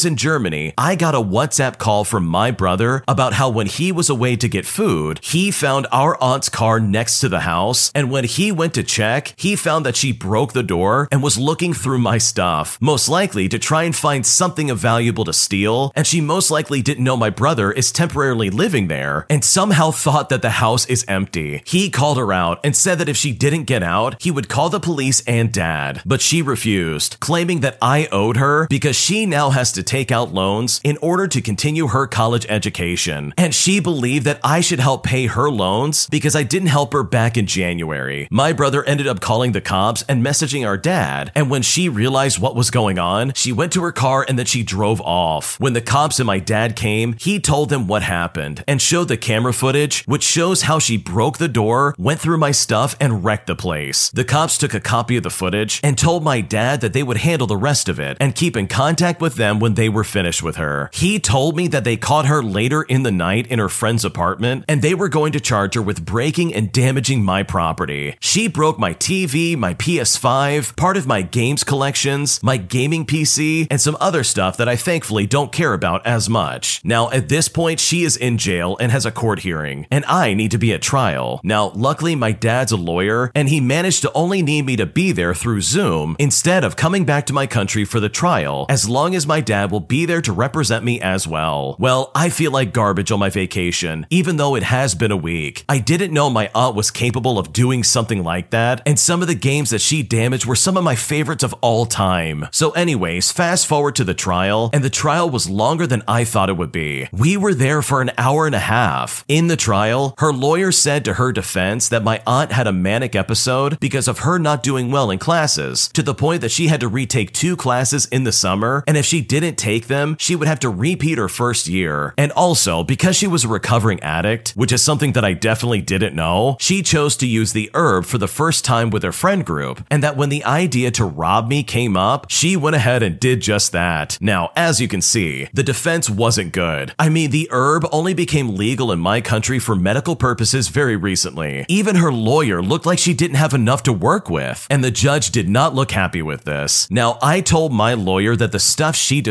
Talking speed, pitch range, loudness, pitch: 230 wpm, 105-150 Hz, -16 LUFS, 125 Hz